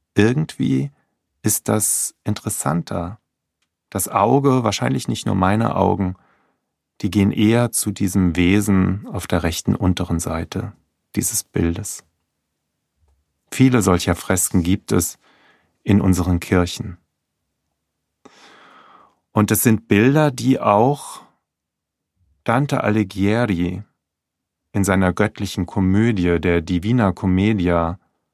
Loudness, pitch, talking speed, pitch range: -19 LUFS, 95 Hz, 100 wpm, 85-105 Hz